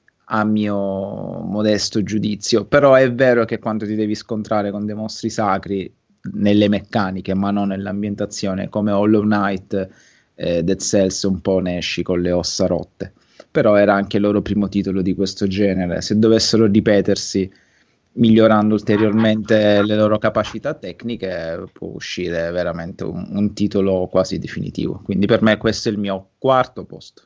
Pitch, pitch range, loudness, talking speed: 105 Hz, 95-110 Hz, -18 LUFS, 155 wpm